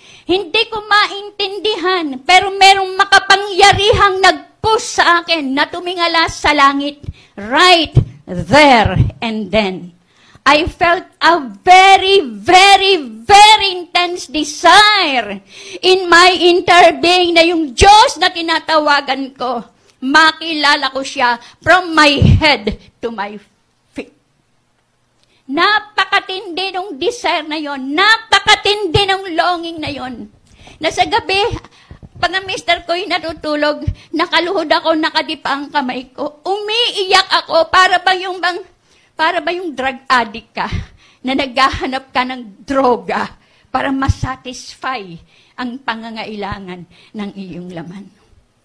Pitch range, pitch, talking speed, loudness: 265-375 Hz, 335 Hz, 110 wpm, -12 LUFS